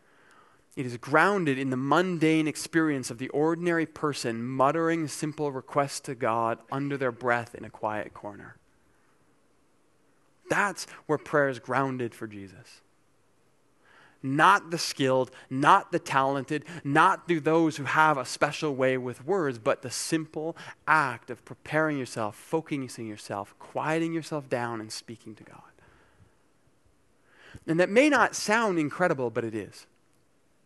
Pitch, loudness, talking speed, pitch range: 145 Hz, -27 LUFS, 140 wpm, 130-160 Hz